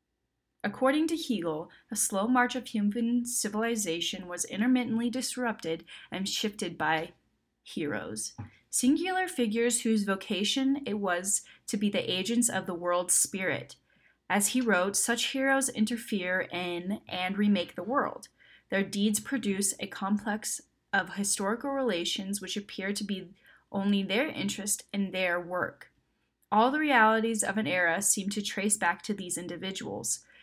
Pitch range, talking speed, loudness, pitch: 190-235 Hz, 140 wpm, -29 LUFS, 210 Hz